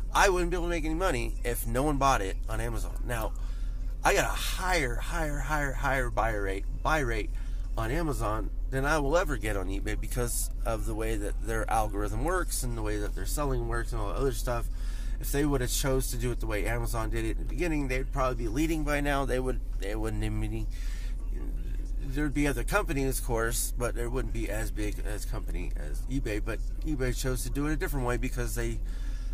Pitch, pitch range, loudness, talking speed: 120 Hz, 105-135 Hz, -31 LUFS, 235 wpm